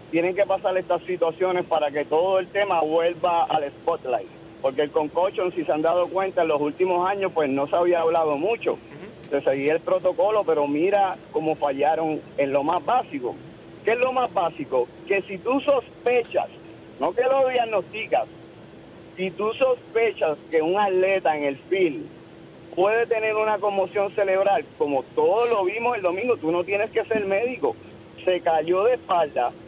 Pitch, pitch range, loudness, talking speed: 190 Hz, 165-225 Hz, -23 LUFS, 175 wpm